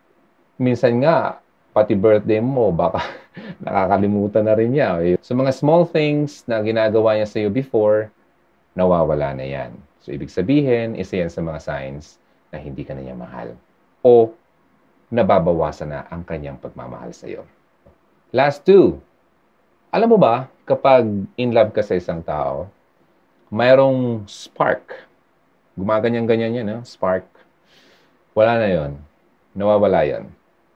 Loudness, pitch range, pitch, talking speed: -18 LUFS, 100-125 Hz, 110 Hz, 130 wpm